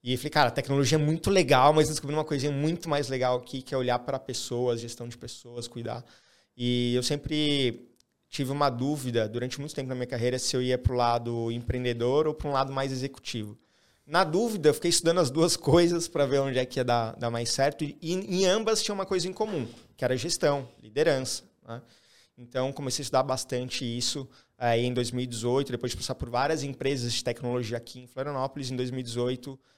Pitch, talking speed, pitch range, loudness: 130 Hz, 210 wpm, 120-145 Hz, -28 LUFS